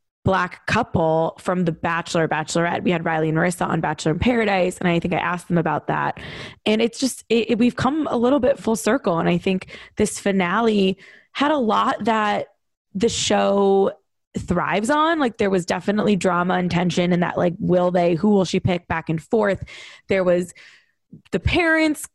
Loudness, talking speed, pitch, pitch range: -20 LUFS, 190 wpm, 190 Hz, 175-225 Hz